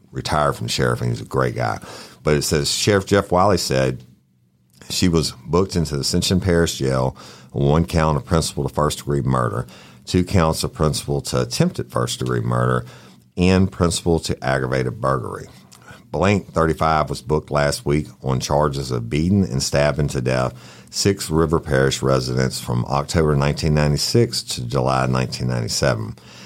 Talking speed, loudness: 155 wpm, -20 LUFS